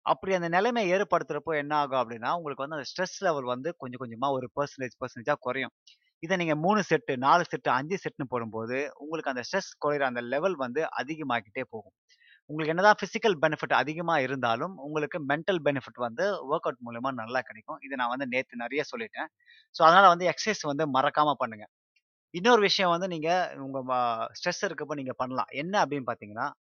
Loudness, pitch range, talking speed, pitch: -28 LUFS, 130-175 Hz, 175 wpm, 150 Hz